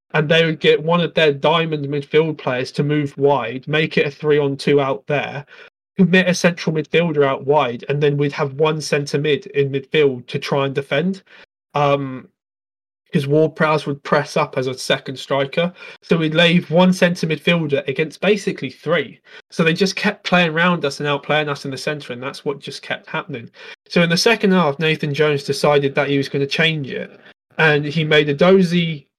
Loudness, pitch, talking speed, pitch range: -18 LUFS, 150 Hz, 200 wpm, 140-170 Hz